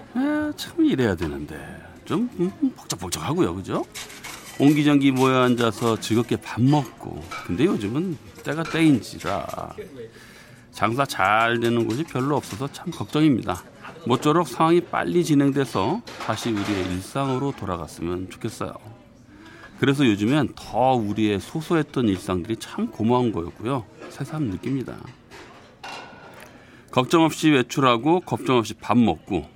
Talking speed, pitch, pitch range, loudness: 280 characters per minute, 130 Hz, 110-155 Hz, -23 LUFS